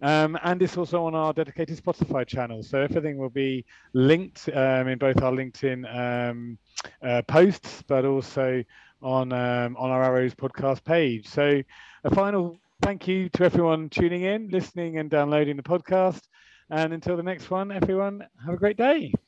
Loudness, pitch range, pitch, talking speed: -25 LUFS, 130-175 Hz, 155 Hz, 170 wpm